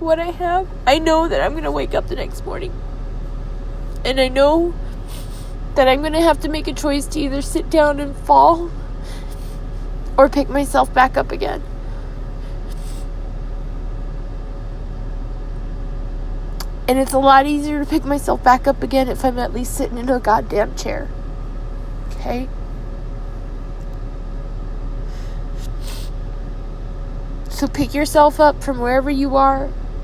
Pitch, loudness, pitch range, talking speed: 280 Hz, -18 LUFS, 265-310 Hz, 135 wpm